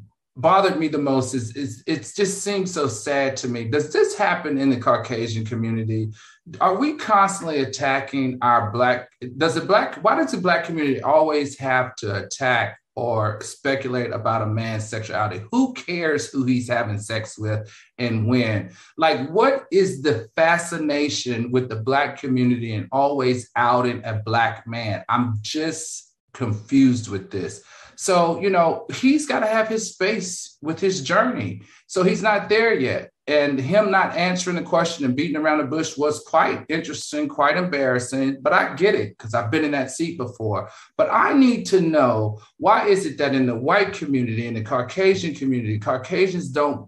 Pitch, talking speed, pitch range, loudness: 140 Hz, 175 wpm, 120-170 Hz, -21 LUFS